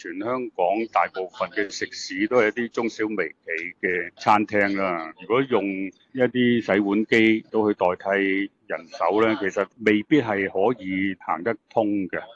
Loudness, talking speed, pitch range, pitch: -23 LUFS, 230 characters per minute, 95-115 Hz, 105 Hz